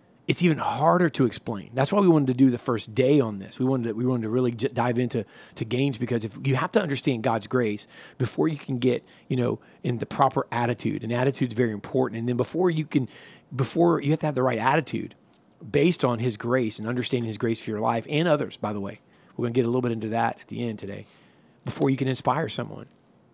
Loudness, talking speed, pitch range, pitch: -25 LUFS, 250 wpm, 115-140 Hz, 125 Hz